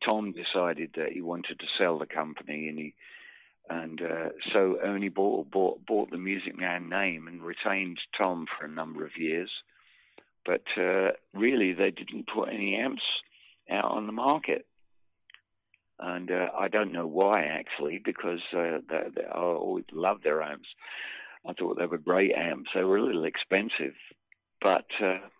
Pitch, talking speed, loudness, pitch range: 85 Hz, 170 wpm, -30 LUFS, 80-100 Hz